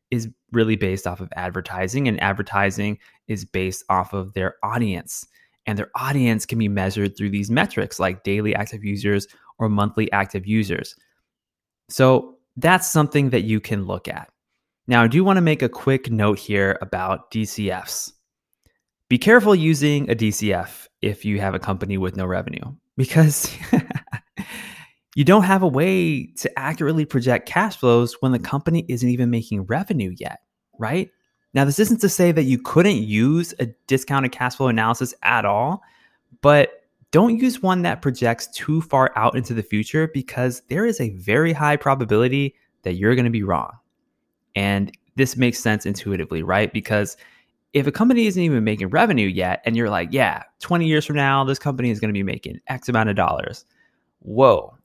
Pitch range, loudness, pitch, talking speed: 100-145 Hz, -20 LUFS, 120 Hz, 175 wpm